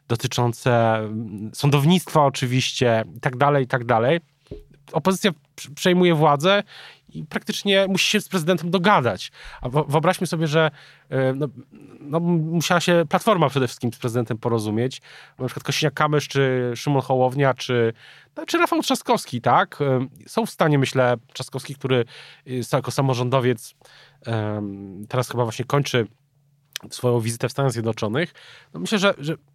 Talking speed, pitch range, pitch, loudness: 135 wpm, 125-165 Hz, 140 Hz, -21 LUFS